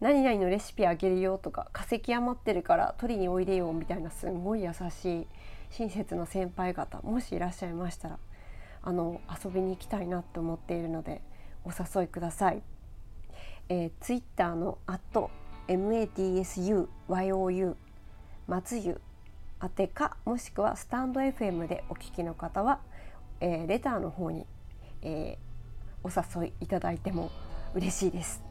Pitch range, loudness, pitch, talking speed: 165-195 Hz, -33 LUFS, 180 Hz, 295 characters per minute